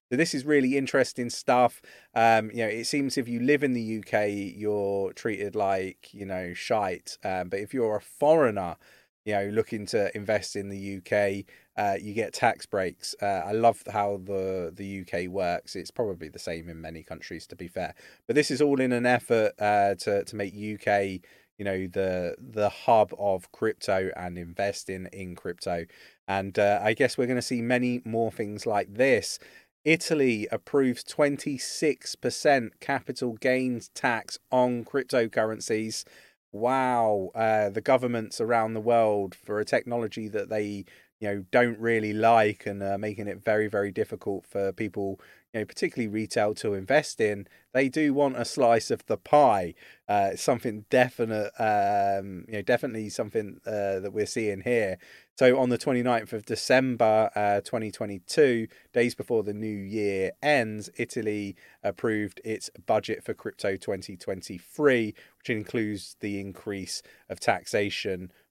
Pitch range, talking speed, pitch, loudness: 100-120 Hz, 160 wpm, 110 Hz, -27 LUFS